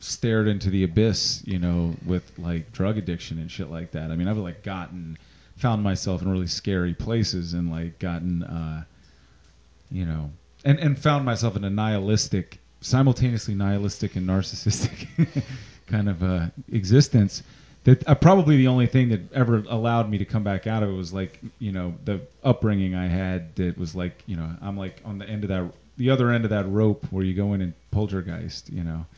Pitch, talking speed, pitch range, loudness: 100 Hz, 195 wpm, 90-115 Hz, -24 LUFS